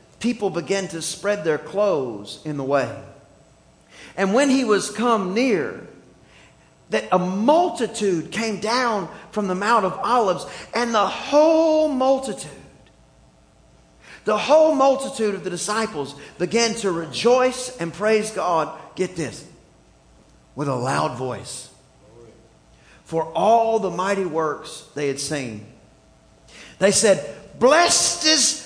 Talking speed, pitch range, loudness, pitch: 125 wpm, 145-225 Hz, -21 LUFS, 190 Hz